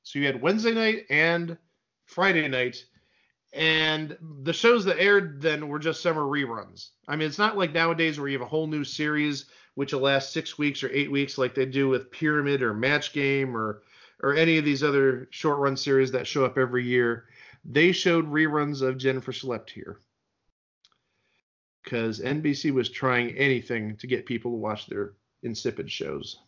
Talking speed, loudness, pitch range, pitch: 185 wpm, -25 LUFS, 130-155 Hz, 140 Hz